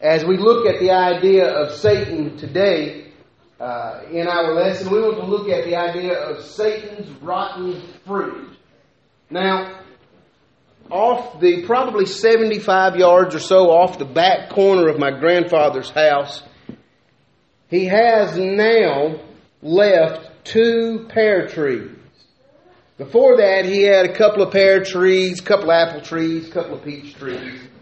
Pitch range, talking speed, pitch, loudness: 165-200 Hz, 140 wpm, 185 Hz, -16 LUFS